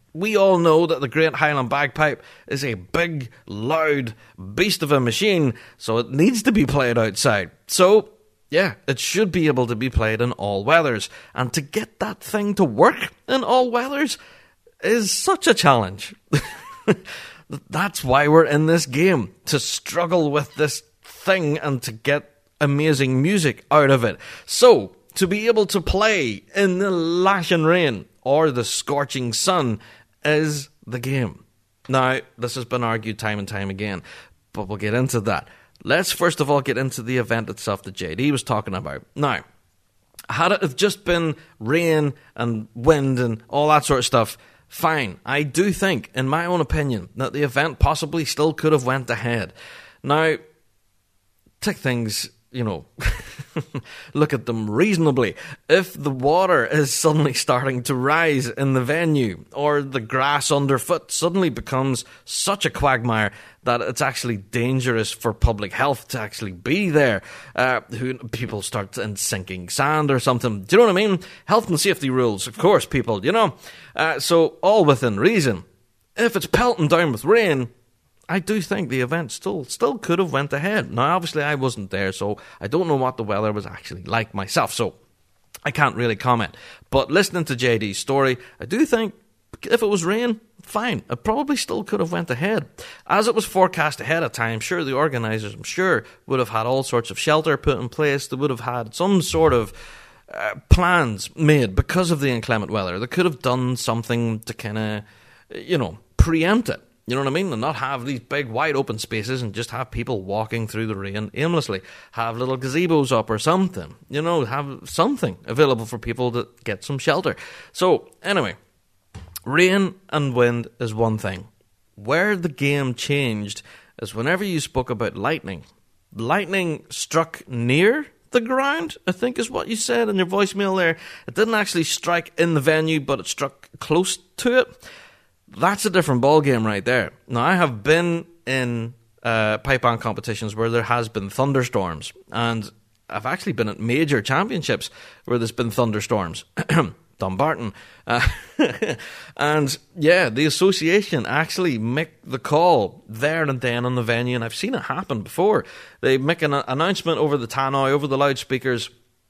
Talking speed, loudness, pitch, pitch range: 175 wpm, -21 LUFS, 135 Hz, 115-165 Hz